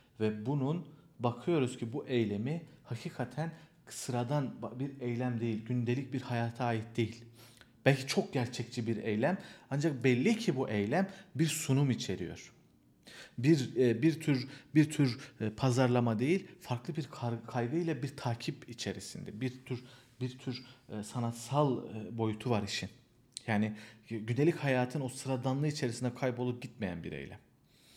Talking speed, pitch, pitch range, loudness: 130 wpm, 125 Hz, 115-145 Hz, -34 LUFS